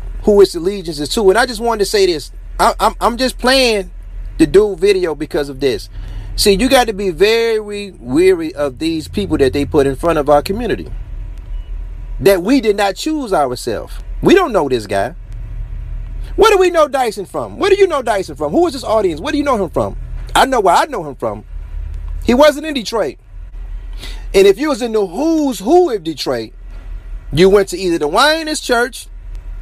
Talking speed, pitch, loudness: 205 wpm, 225 Hz, -14 LUFS